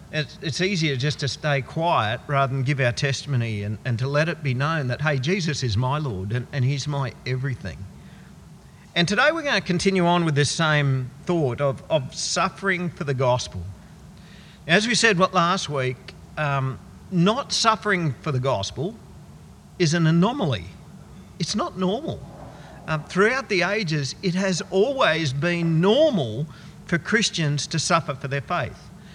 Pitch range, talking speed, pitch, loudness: 135-180 Hz, 165 wpm, 155 Hz, -23 LUFS